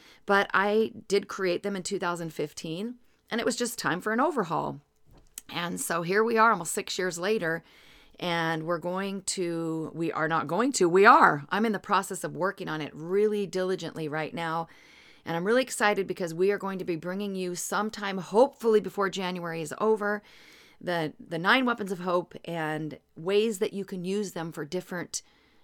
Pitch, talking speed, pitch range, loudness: 185 Hz, 185 wpm, 165-210 Hz, -28 LUFS